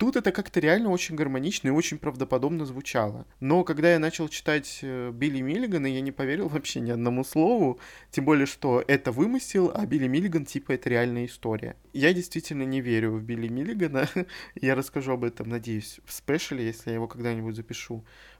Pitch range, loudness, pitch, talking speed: 120-160 Hz, -27 LUFS, 135 Hz, 180 wpm